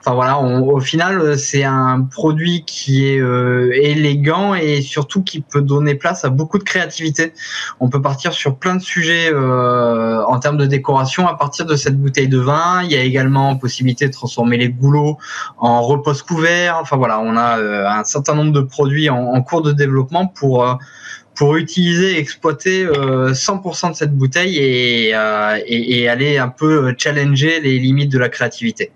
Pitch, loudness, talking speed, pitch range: 140 Hz, -15 LUFS, 185 wpm, 130-160 Hz